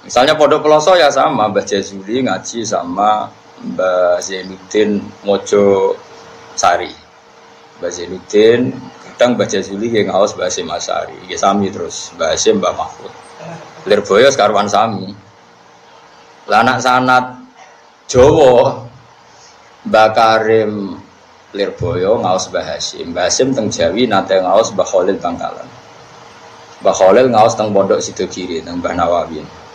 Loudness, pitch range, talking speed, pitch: -13 LUFS, 100-135 Hz, 120 wpm, 110 Hz